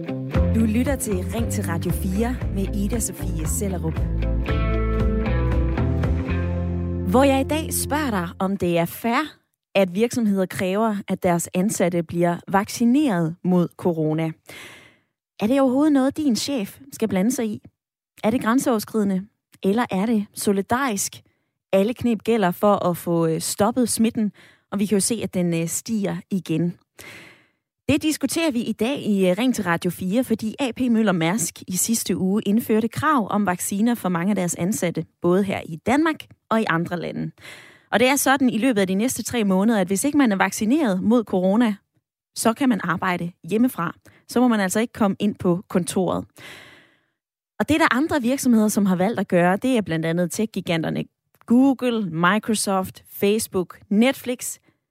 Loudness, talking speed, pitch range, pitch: -22 LUFS, 165 wpm, 175-235 Hz, 200 Hz